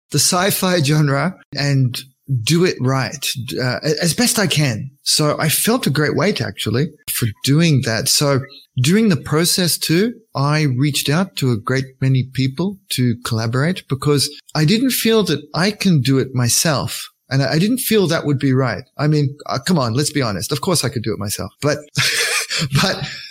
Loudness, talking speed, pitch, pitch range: -17 LUFS, 185 wpm, 145 Hz, 130-170 Hz